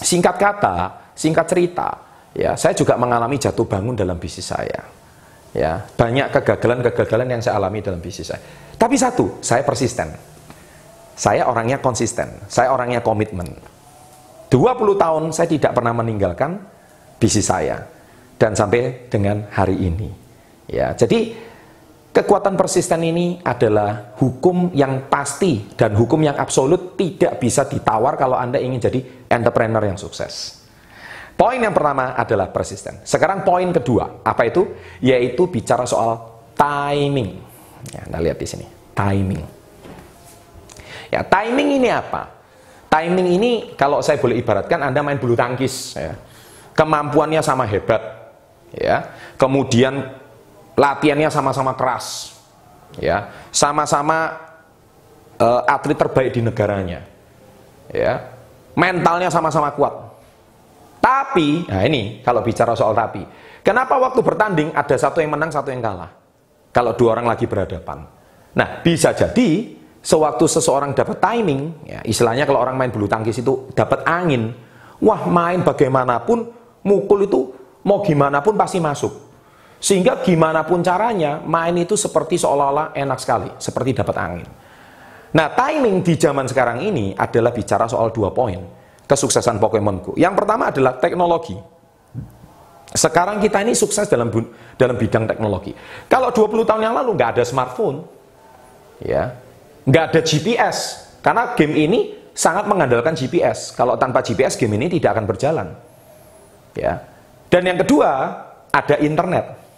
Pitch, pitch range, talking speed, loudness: 140 Hz, 115-170 Hz, 130 wpm, -18 LUFS